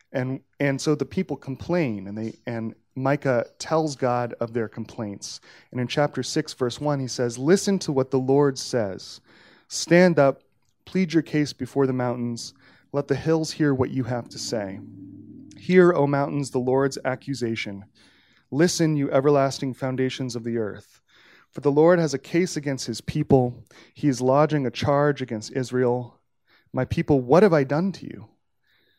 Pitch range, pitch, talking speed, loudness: 125-150 Hz, 135 Hz, 170 wpm, -24 LUFS